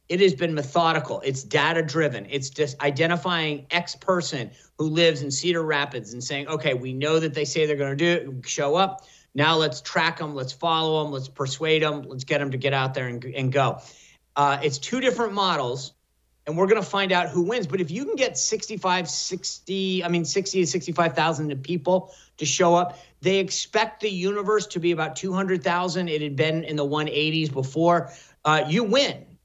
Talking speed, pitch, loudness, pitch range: 200 wpm, 160 Hz, -24 LUFS, 145-180 Hz